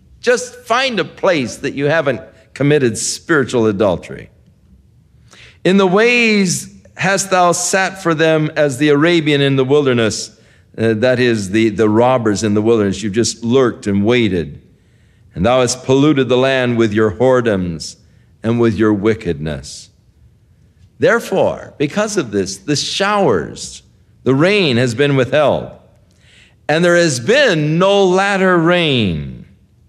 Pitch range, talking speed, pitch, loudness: 110-165 Hz, 140 wpm, 125 Hz, -14 LUFS